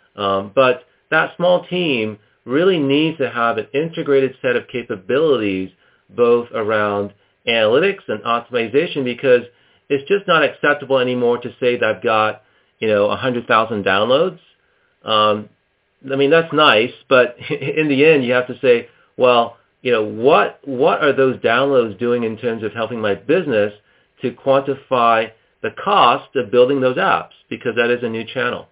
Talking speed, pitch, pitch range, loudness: 160 wpm, 120 Hz, 110-140 Hz, -17 LUFS